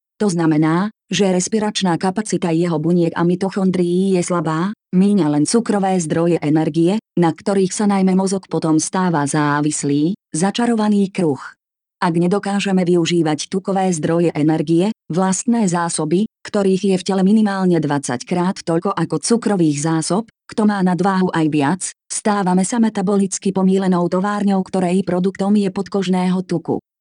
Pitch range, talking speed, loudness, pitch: 165-195 Hz, 135 wpm, -17 LUFS, 185 Hz